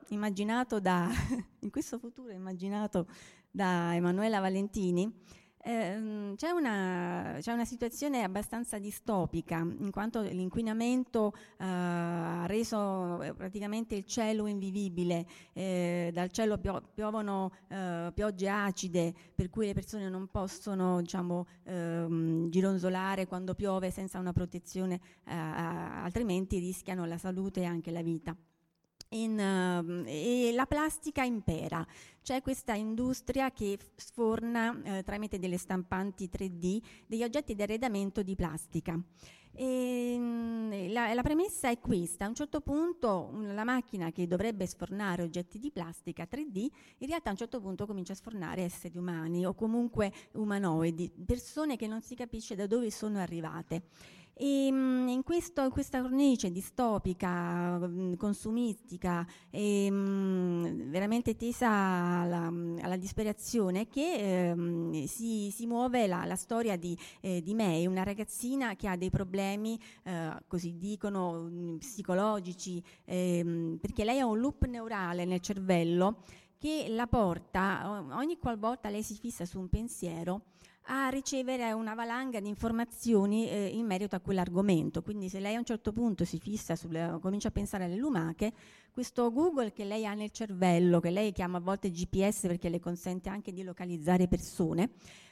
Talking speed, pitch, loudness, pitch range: 145 wpm, 195 Hz, -34 LUFS, 180-230 Hz